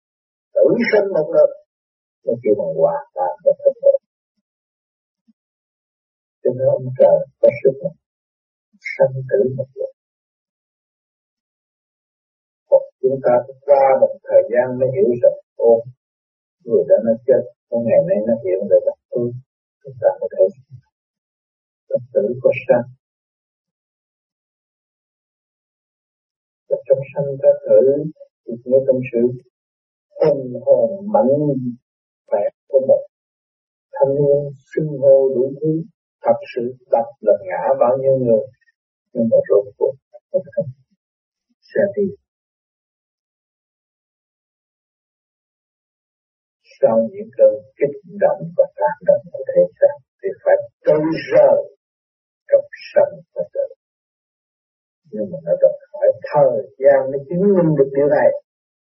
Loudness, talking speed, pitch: -17 LUFS, 240 wpm, 260 Hz